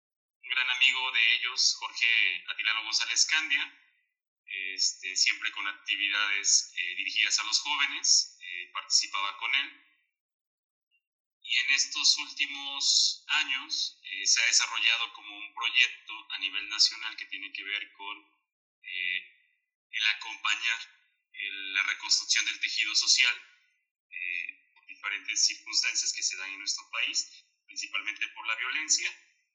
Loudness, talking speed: -27 LUFS, 130 wpm